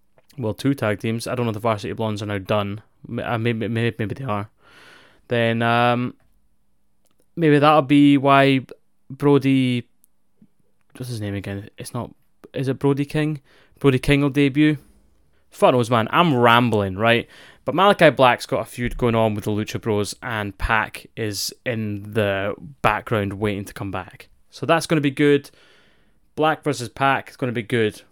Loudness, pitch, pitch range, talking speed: -20 LUFS, 120 Hz, 105-140 Hz, 175 wpm